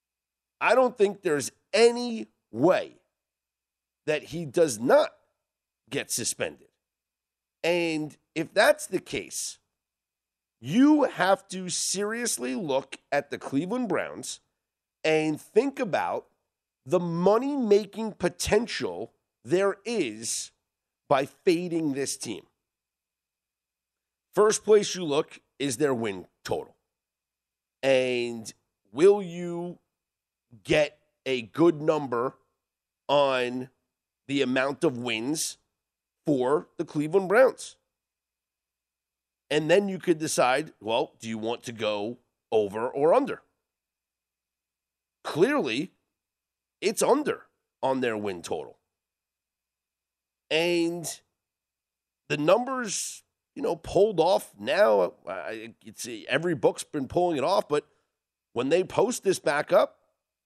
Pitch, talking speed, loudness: 140 Hz, 105 wpm, -26 LUFS